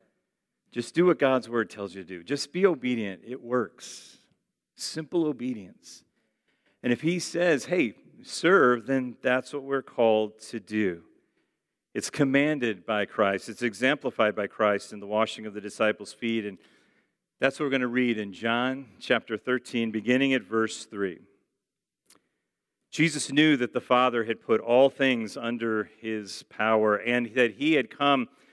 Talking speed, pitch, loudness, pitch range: 160 wpm, 120 Hz, -26 LUFS, 110-135 Hz